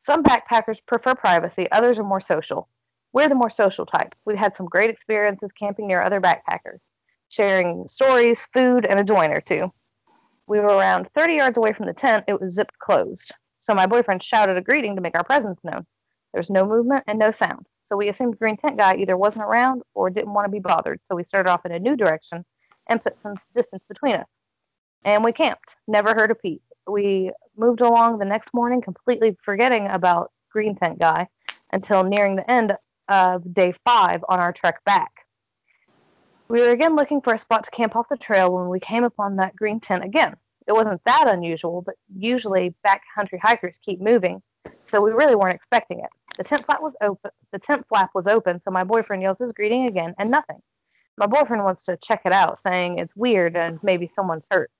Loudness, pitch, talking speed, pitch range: -20 LUFS, 210 Hz, 210 wpm, 190-235 Hz